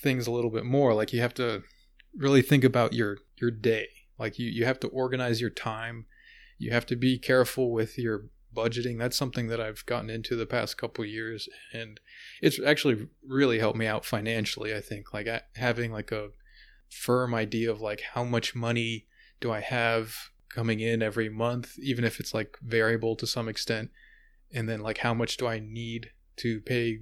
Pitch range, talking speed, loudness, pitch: 110-125 Hz, 200 wpm, -29 LUFS, 115 Hz